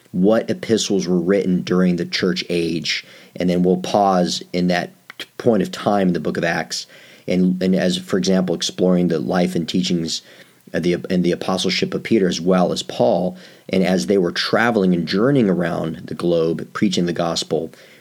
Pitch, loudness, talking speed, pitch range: 90 Hz, -19 LUFS, 185 wpm, 85-90 Hz